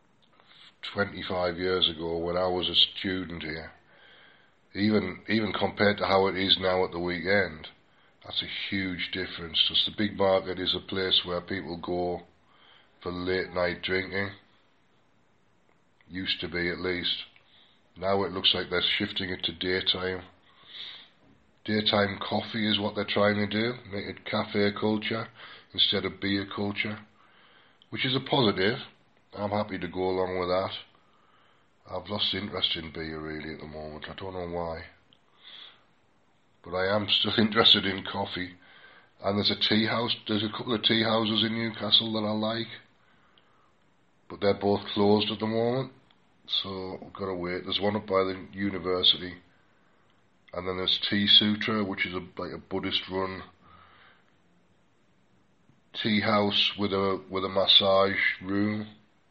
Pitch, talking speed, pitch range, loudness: 95 Hz, 155 wpm, 90-105 Hz, -27 LUFS